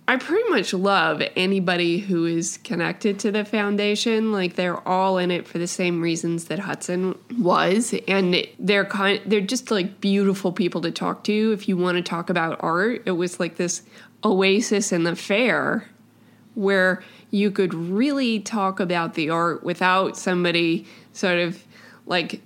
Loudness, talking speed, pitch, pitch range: -22 LUFS, 165 wpm, 190 Hz, 175-210 Hz